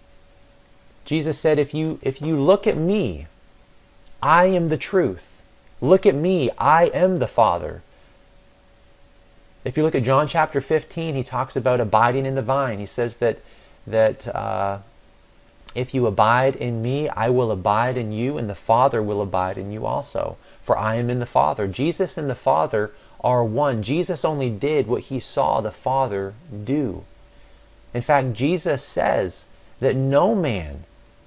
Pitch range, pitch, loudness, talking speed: 105-150 Hz, 125 Hz, -21 LUFS, 165 wpm